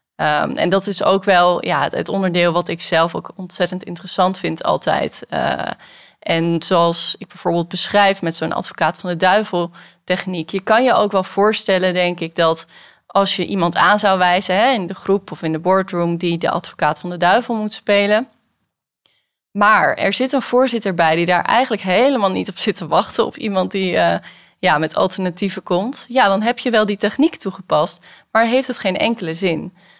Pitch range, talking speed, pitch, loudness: 175-205 Hz, 195 wpm, 185 Hz, -17 LUFS